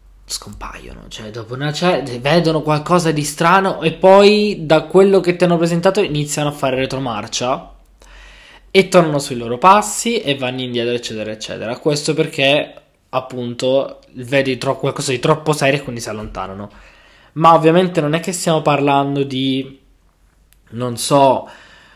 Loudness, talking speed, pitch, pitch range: -16 LUFS, 150 wpm, 140 Hz, 125-165 Hz